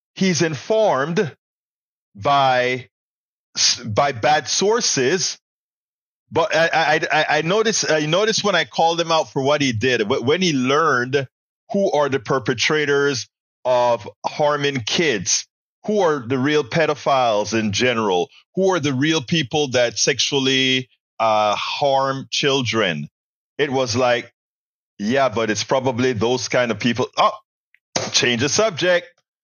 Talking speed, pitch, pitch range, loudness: 130 wpm, 140 Hz, 125-160 Hz, -19 LUFS